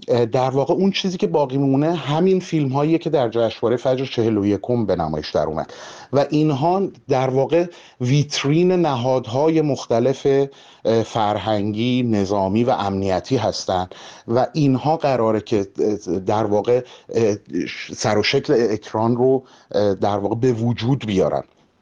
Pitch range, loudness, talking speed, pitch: 110-145 Hz, -20 LUFS, 130 wpm, 130 Hz